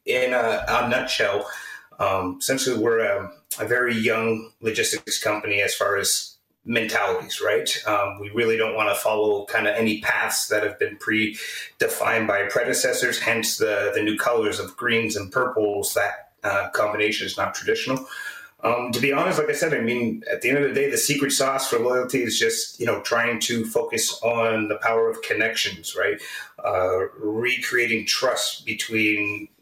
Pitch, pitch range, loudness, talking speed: 115 Hz, 110-135 Hz, -22 LUFS, 180 wpm